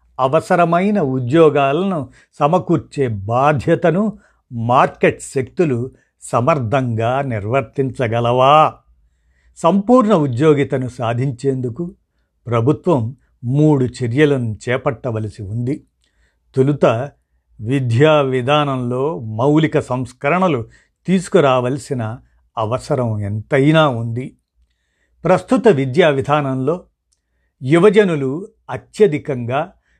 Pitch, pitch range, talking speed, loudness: 135 Hz, 115-155 Hz, 60 wpm, -16 LUFS